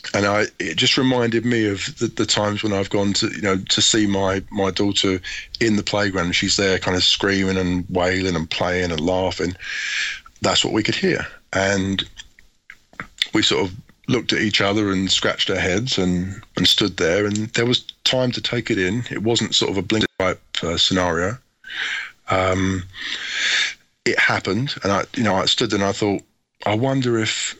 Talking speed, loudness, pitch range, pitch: 195 wpm, -20 LUFS, 95-110 Hz, 100 Hz